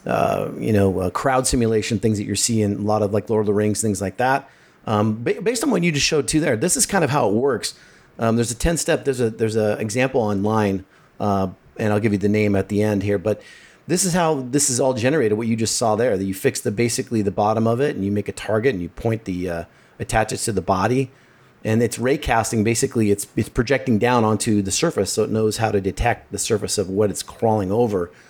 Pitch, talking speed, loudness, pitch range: 110 Hz, 255 wpm, -20 LUFS, 105-130 Hz